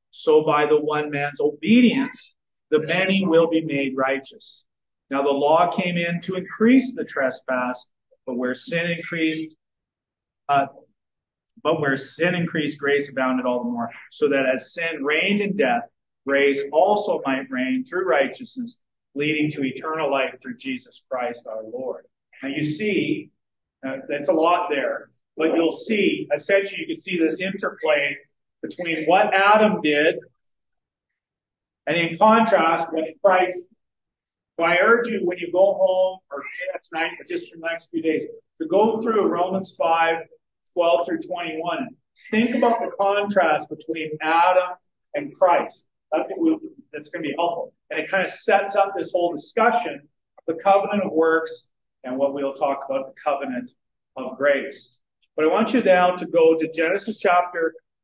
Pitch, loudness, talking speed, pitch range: 165 Hz, -21 LUFS, 160 wpm, 145-200 Hz